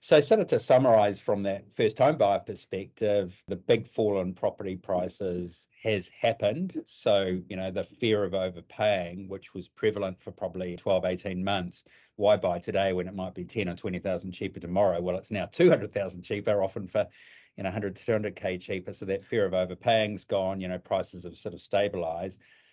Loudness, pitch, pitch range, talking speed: -29 LUFS, 95 Hz, 90-100 Hz, 190 wpm